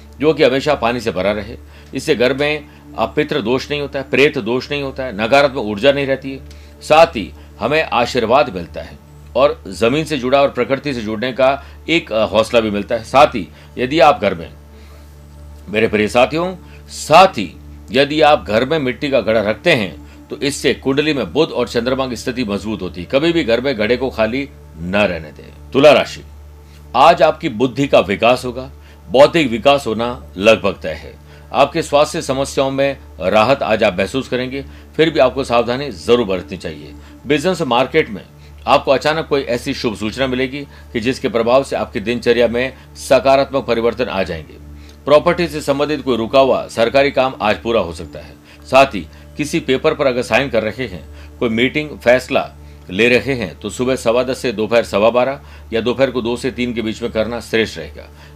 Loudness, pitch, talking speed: -16 LUFS, 120 Hz, 190 wpm